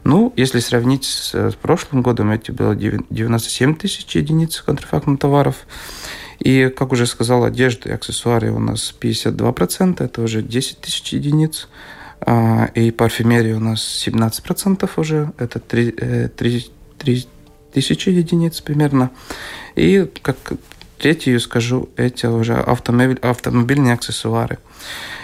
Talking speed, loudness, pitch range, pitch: 115 wpm, -17 LUFS, 115-140 Hz, 125 Hz